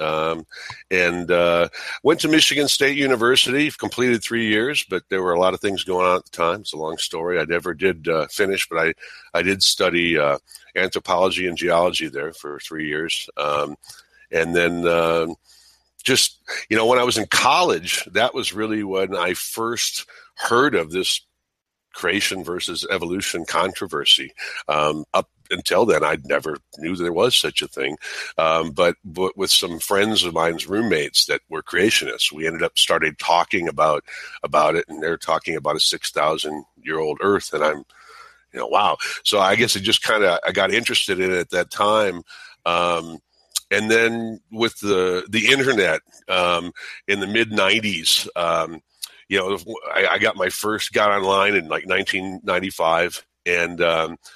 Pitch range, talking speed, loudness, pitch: 85-105 Hz, 175 wpm, -20 LUFS, 90 Hz